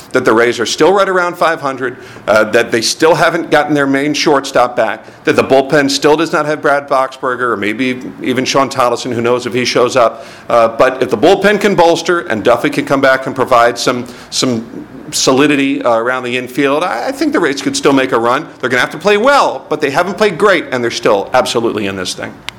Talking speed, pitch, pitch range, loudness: 235 wpm, 140 Hz, 125-170 Hz, -12 LUFS